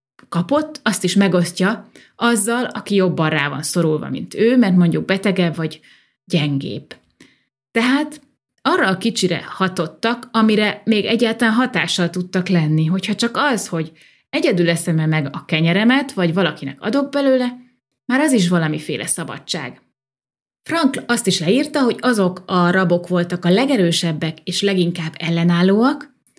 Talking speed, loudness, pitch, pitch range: 135 wpm, -18 LUFS, 185 Hz, 170-235 Hz